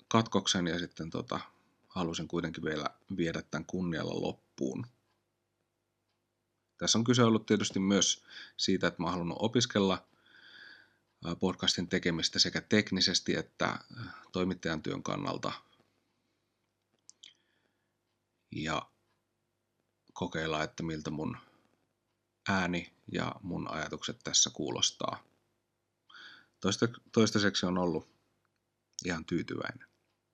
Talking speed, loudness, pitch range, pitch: 95 wpm, -32 LUFS, 85-110 Hz, 95 Hz